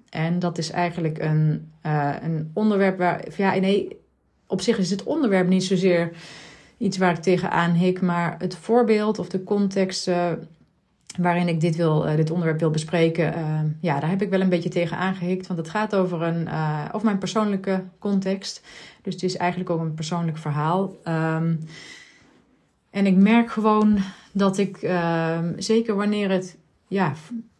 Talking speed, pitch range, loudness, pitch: 175 wpm, 165-195 Hz, -23 LUFS, 180 Hz